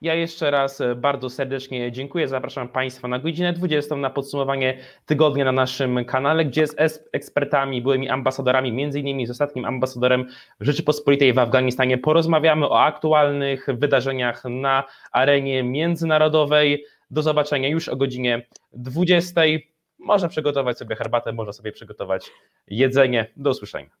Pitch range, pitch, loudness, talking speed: 130-155 Hz, 135 Hz, -21 LUFS, 130 wpm